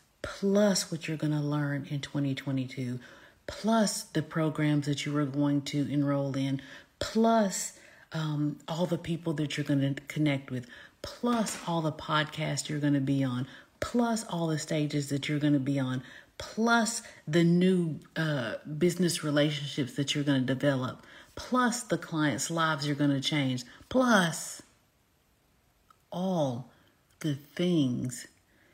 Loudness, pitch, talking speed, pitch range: -30 LUFS, 150 Hz, 150 wpm, 140-175 Hz